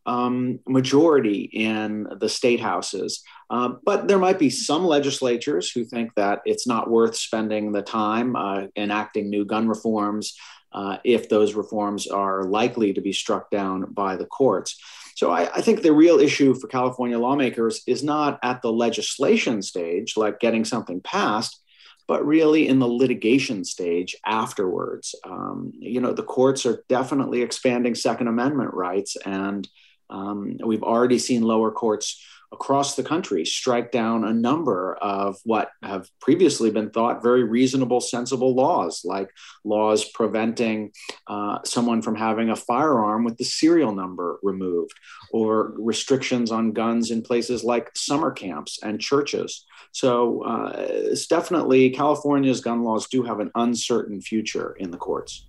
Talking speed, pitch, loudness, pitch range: 150 wpm, 115 Hz, -22 LUFS, 105-125 Hz